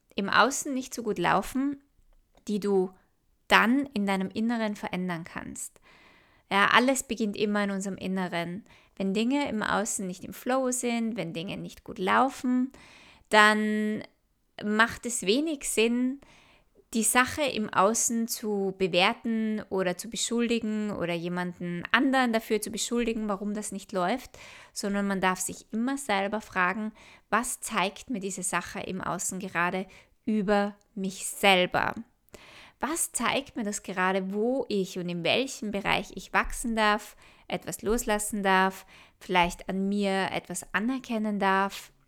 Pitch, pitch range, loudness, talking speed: 210 Hz, 190-230 Hz, -28 LUFS, 140 wpm